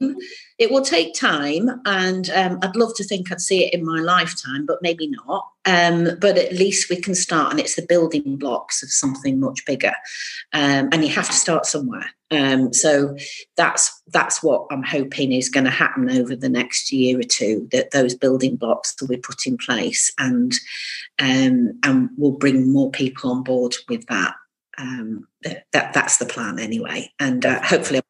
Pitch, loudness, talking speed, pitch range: 160 Hz, -19 LUFS, 190 wpm, 135-195 Hz